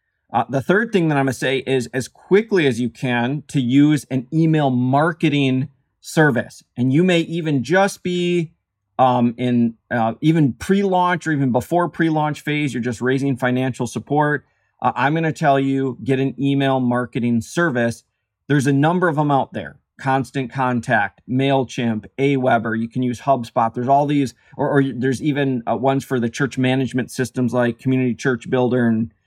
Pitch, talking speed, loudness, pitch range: 135 Hz, 180 wpm, -19 LUFS, 125-150 Hz